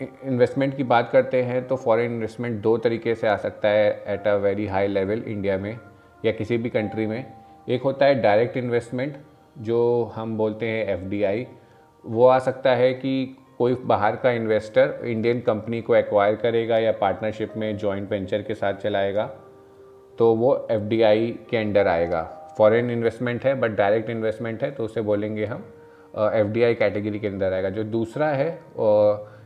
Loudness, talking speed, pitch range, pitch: -23 LUFS, 170 wpm, 105-125 Hz, 115 Hz